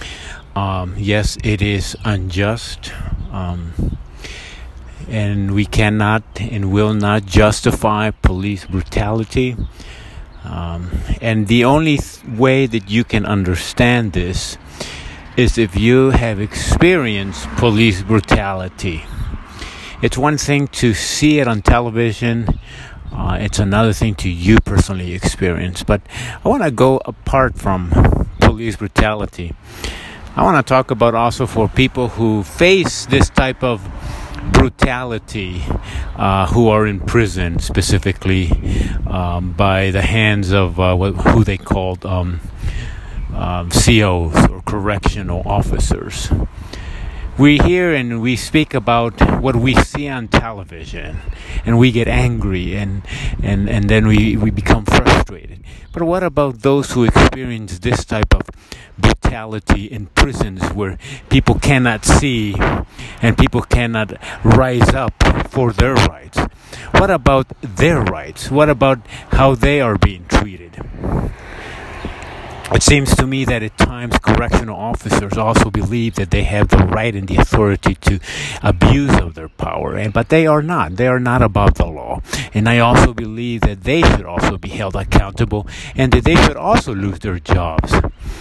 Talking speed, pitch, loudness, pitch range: 140 wpm, 105 Hz, -15 LUFS, 90-120 Hz